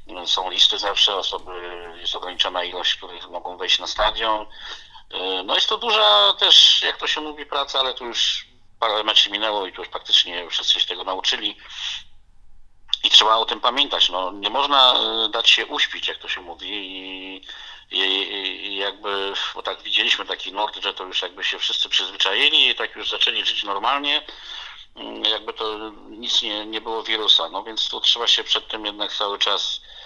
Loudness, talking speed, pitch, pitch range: -19 LUFS, 180 wpm, 105 Hz, 95-150 Hz